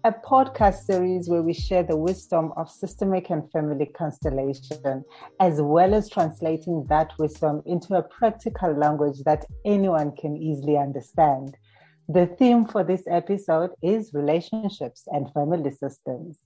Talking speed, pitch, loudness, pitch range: 140 wpm, 160 Hz, -24 LUFS, 150-185 Hz